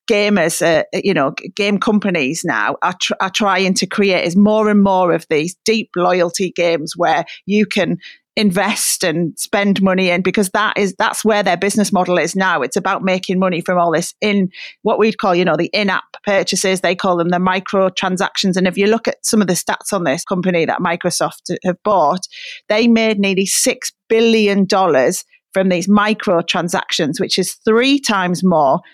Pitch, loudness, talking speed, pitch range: 195 Hz, -15 LUFS, 195 wpm, 180-210 Hz